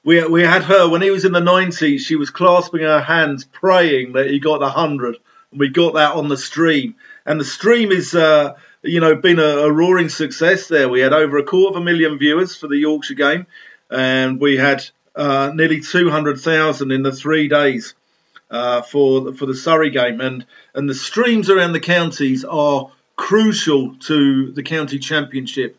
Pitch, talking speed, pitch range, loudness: 155 Hz, 195 wpm, 140-175 Hz, -15 LUFS